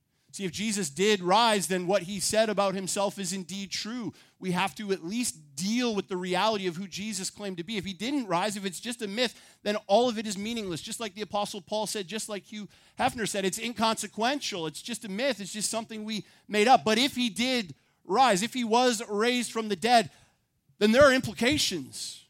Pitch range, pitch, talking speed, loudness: 195-230 Hz, 210 Hz, 225 wpm, -28 LUFS